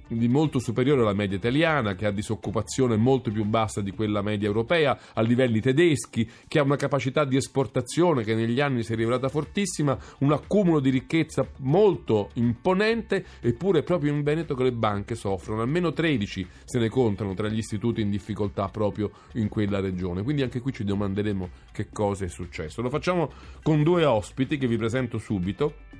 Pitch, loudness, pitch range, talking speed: 120 Hz, -25 LUFS, 105-145 Hz, 180 wpm